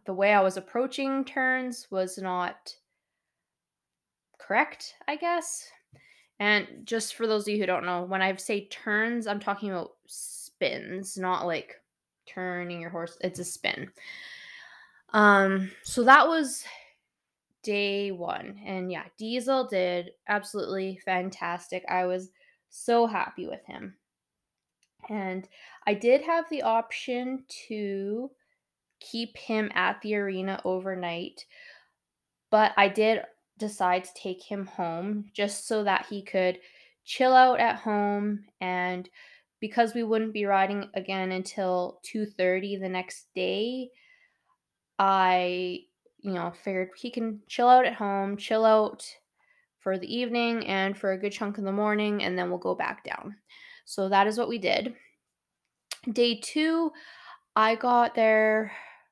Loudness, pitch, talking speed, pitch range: -27 LUFS, 205 Hz, 140 wpm, 190-240 Hz